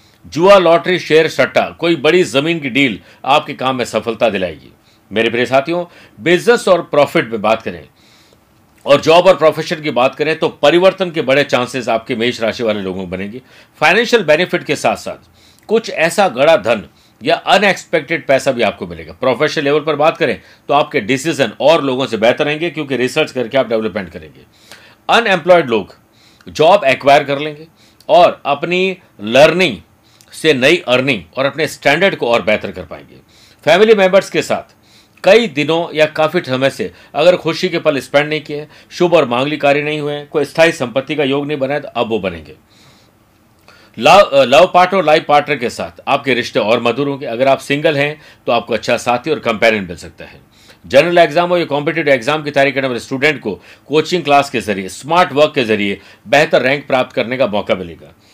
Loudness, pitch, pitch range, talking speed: -13 LUFS, 145 Hz, 115-165 Hz, 185 wpm